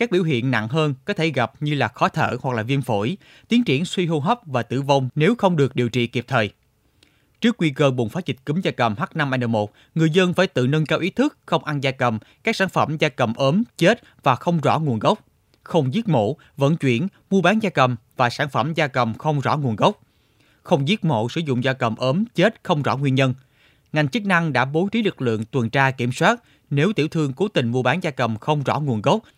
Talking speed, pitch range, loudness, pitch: 245 wpm, 125-175 Hz, -21 LUFS, 145 Hz